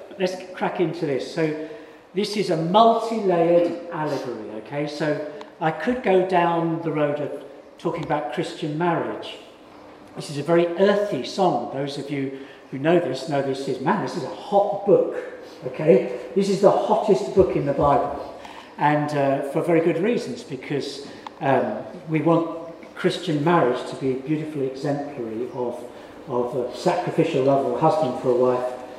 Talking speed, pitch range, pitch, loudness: 170 wpm, 140-180 Hz, 160 Hz, -23 LUFS